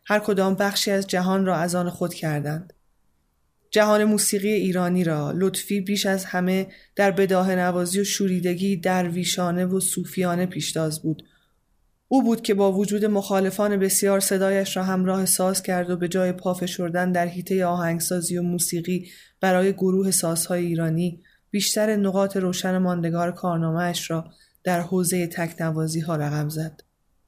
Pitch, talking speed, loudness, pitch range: 180 Hz, 145 wpm, -23 LUFS, 175-195 Hz